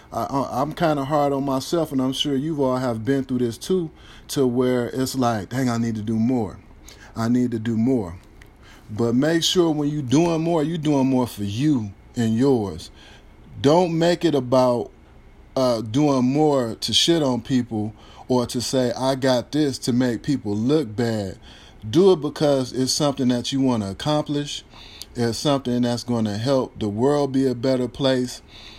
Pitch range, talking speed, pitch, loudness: 115-145 Hz, 190 wpm, 130 Hz, -22 LUFS